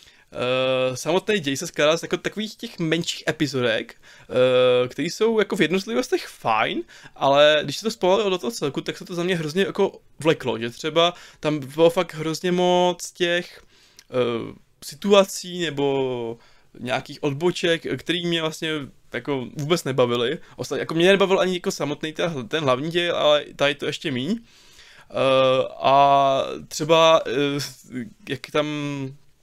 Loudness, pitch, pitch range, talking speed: -22 LUFS, 160 Hz, 140-180 Hz, 155 wpm